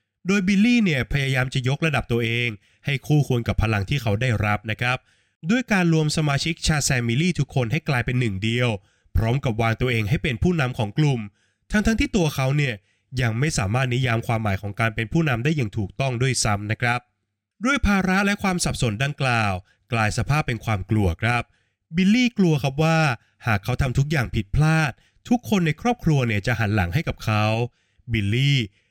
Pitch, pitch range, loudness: 125 Hz, 110-155 Hz, -22 LUFS